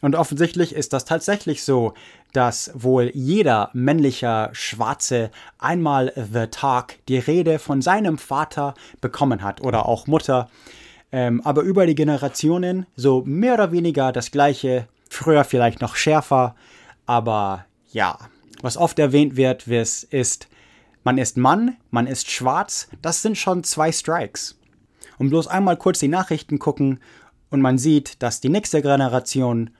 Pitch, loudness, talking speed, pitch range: 140 Hz, -20 LUFS, 145 wpm, 125-160 Hz